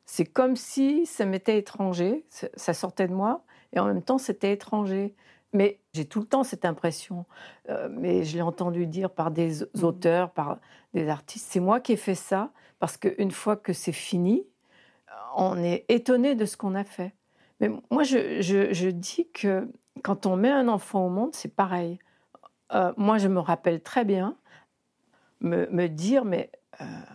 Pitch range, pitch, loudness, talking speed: 180-240 Hz, 200 Hz, -27 LUFS, 185 wpm